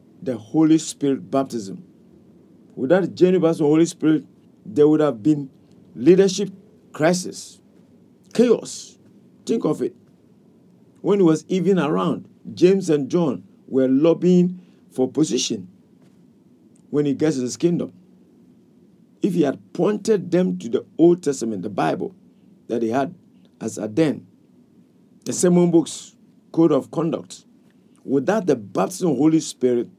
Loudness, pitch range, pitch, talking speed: -20 LUFS, 145-185 Hz, 160 Hz, 135 wpm